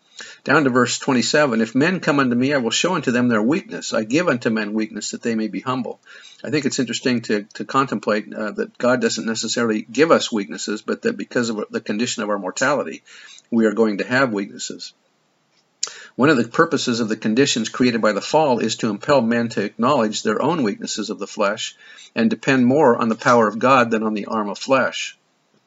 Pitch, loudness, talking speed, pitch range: 120 Hz, -20 LUFS, 215 wpm, 110-135 Hz